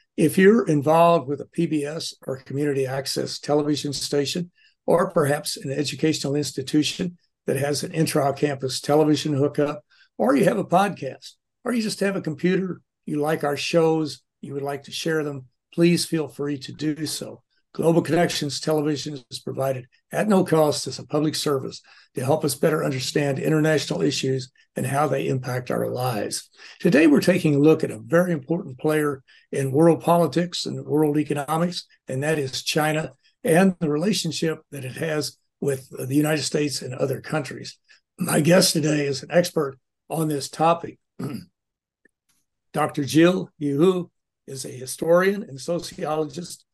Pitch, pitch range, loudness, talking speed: 150 Hz, 140-170 Hz, -23 LUFS, 160 wpm